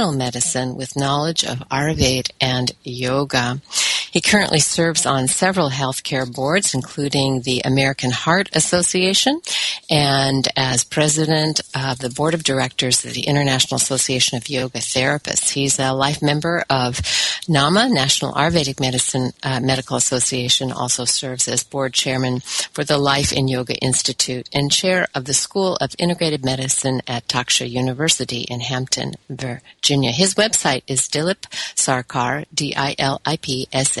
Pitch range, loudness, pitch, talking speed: 130-150 Hz, -18 LUFS, 135 Hz, 135 wpm